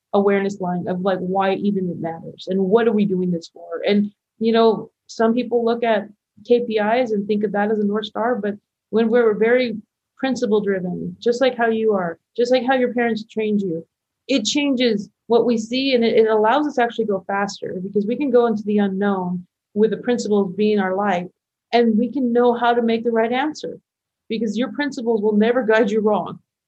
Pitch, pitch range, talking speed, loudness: 220 Hz, 200-240 Hz, 210 wpm, -20 LUFS